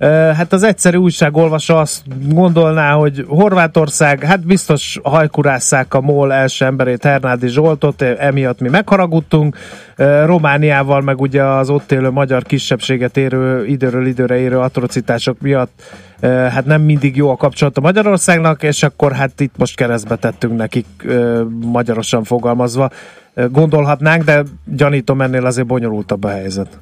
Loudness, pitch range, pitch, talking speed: -13 LUFS, 125-155 Hz, 140 Hz, 135 wpm